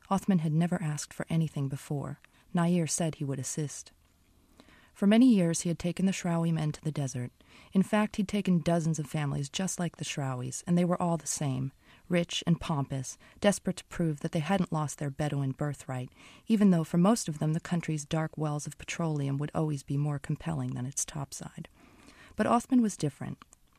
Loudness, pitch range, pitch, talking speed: -30 LUFS, 145-175 Hz, 160 Hz, 195 wpm